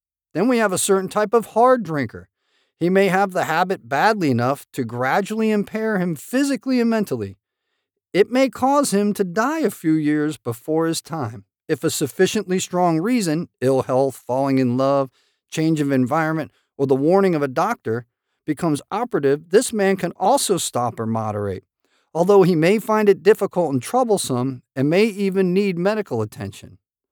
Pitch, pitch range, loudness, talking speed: 165 Hz, 130-205 Hz, -20 LUFS, 170 wpm